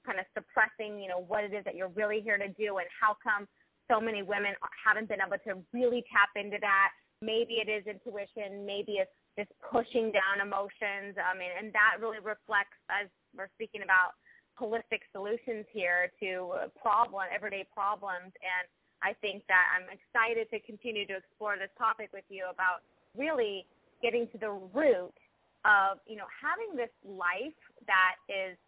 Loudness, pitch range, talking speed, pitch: -32 LUFS, 195-220 Hz, 175 wpm, 205 Hz